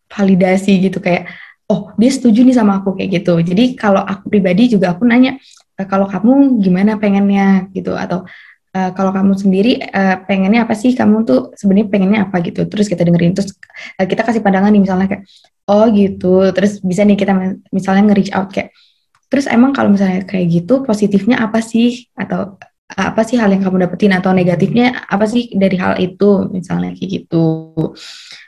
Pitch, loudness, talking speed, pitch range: 195 Hz, -13 LUFS, 175 wpm, 190-220 Hz